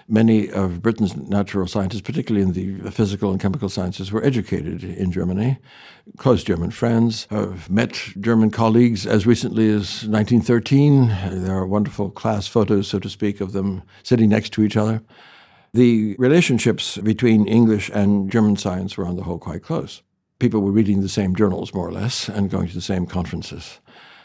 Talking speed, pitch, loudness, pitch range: 175 wpm, 105 Hz, -20 LUFS, 95-115 Hz